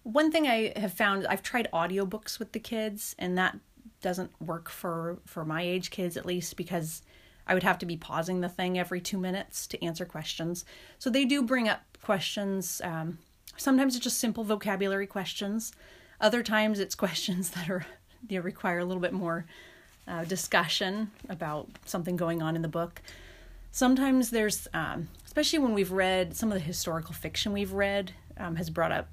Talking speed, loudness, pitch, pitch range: 185 wpm, -30 LUFS, 185 Hz, 175-215 Hz